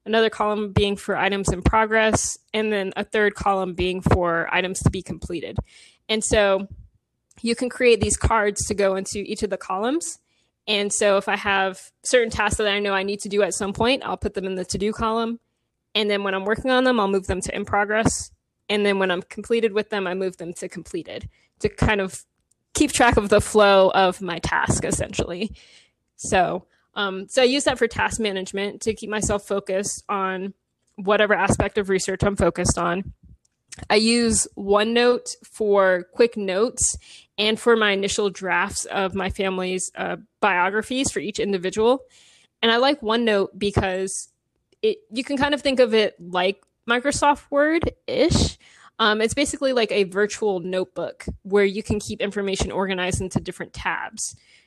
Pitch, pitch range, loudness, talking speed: 205 Hz, 195-230 Hz, -22 LUFS, 185 wpm